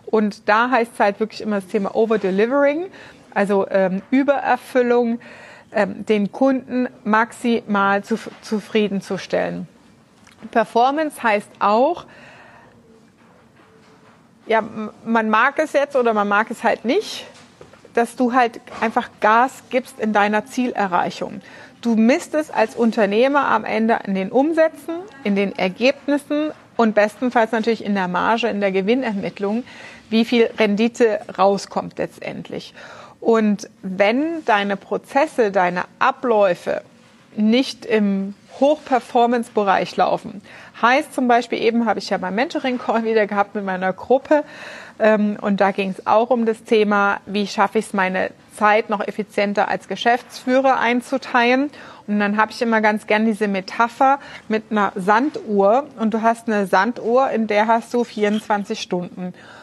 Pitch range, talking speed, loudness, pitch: 205-250 Hz, 135 wpm, -19 LUFS, 225 Hz